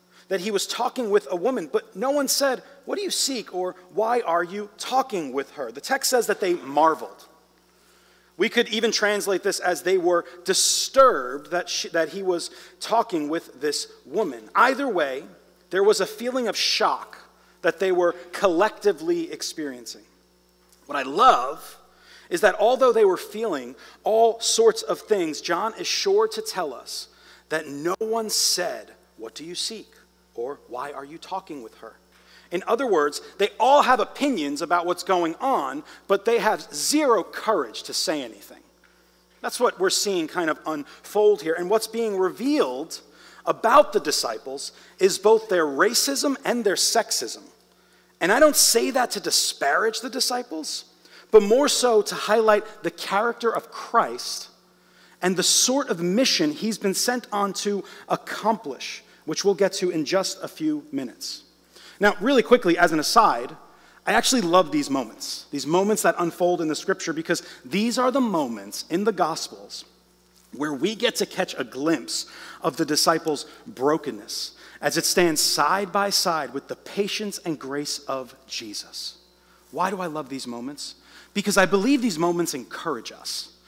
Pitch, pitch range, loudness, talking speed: 200 Hz, 170-255 Hz, -23 LUFS, 170 wpm